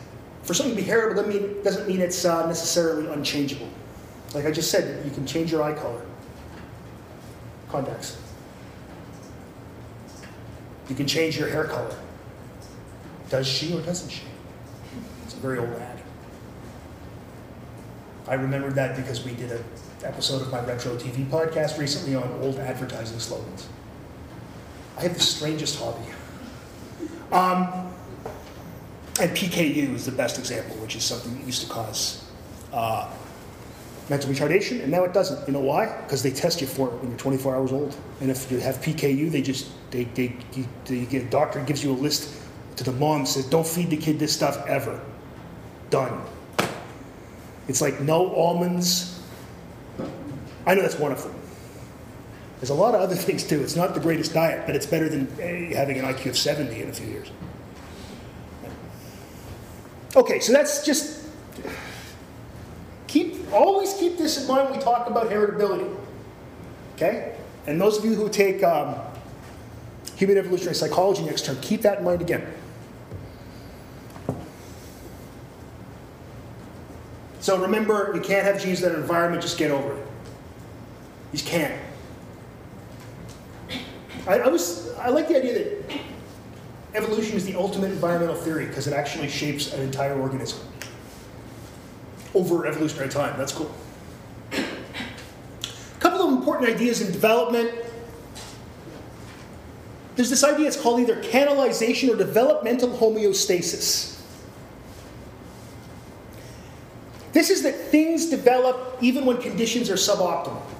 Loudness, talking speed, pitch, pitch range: -24 LUFS, 145 wpm, 155 Hz, 135-200 Hz